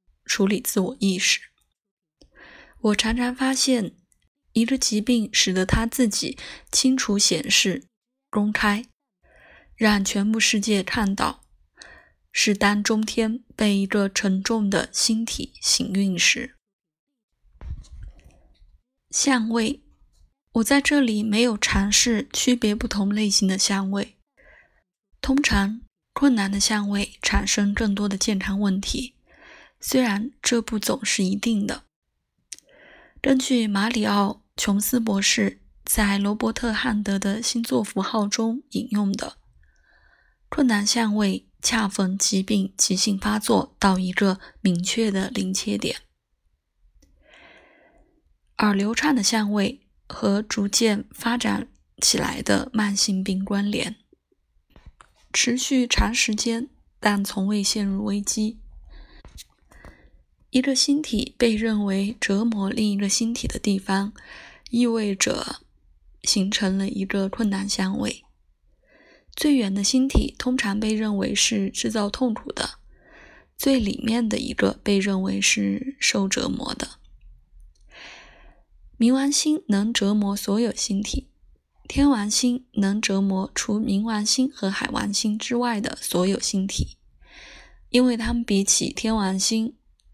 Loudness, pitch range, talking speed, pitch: -22 LUFS, 200-240 Hz, 180 characters per minute, 215 Hz